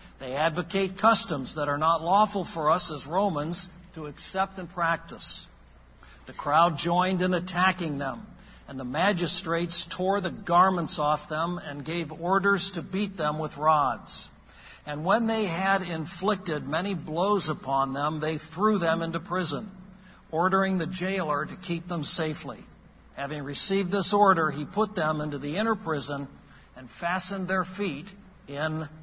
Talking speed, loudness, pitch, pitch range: 155 wpm, -27 LUFS, 170 Hz, 150-190 Hz